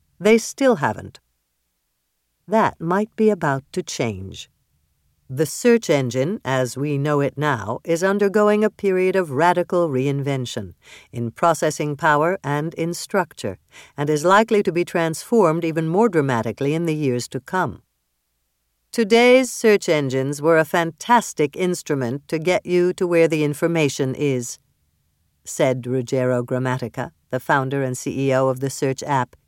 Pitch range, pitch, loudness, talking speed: 125-175 Hz, 145 Hz, -20 LUFS, 140 wpm